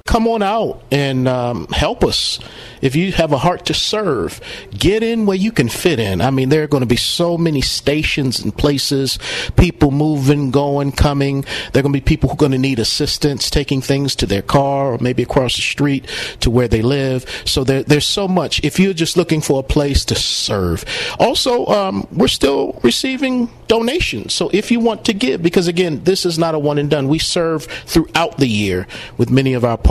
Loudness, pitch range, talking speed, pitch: -16 LUFS, 130-170 Hz, 215 wpm, 145 Hz